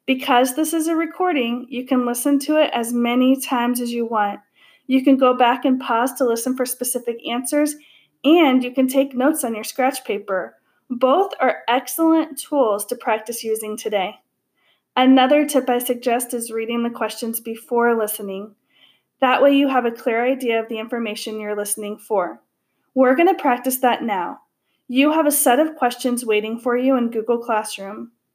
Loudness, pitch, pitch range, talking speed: -19 LUFS, 245 Hz, 230-270 Hz, 180 wpm